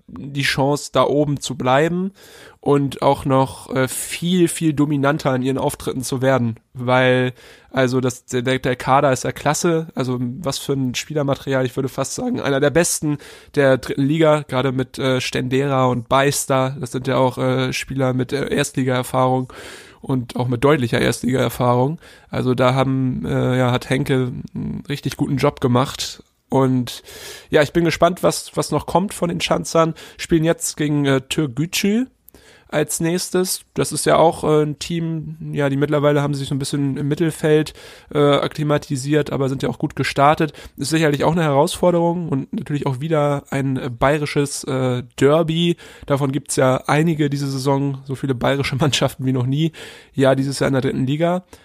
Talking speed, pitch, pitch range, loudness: 180 wpm, 140 Hz, 130-150 Hz, -19 LUFS